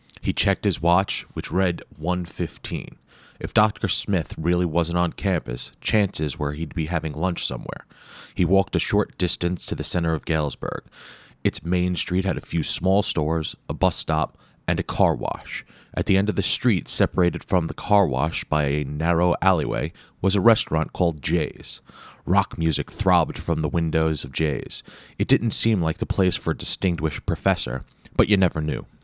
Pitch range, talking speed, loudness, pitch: 80-100 Hz, 185 wpm, -23 LUFS, 90 Hz